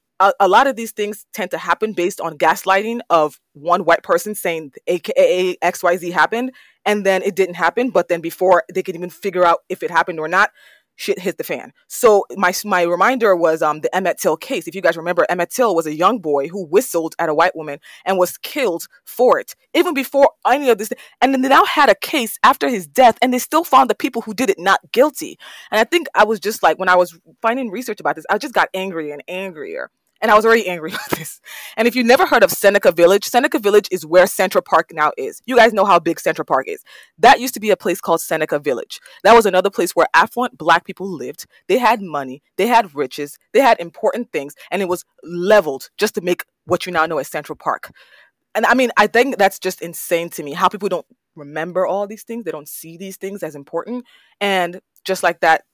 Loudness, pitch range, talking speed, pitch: -17 LUFS, 170-230 Hz, 240 wpm, 190 Hz